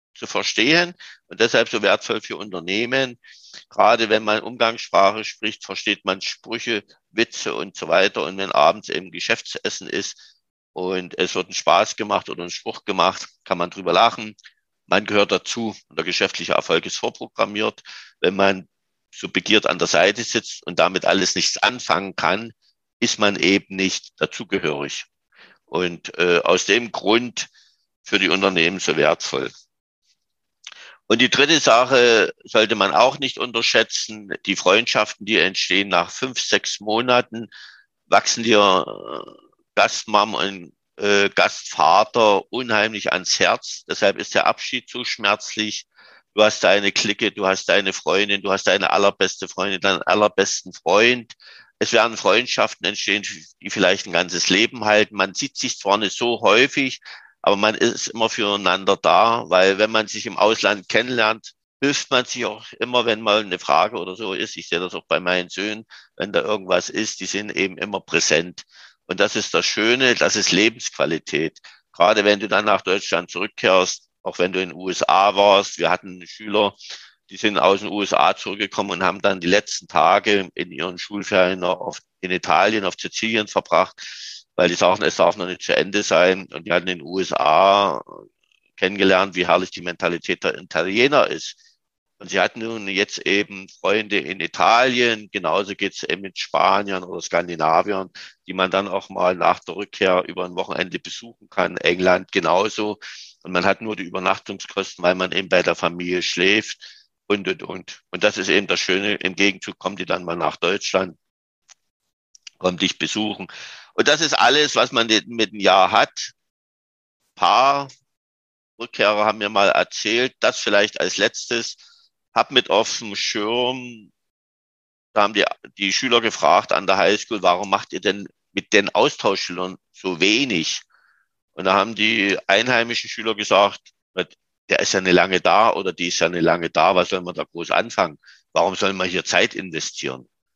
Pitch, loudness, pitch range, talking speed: 100 Hz, -19 LUFS, 90-110 Hz, 170 wpm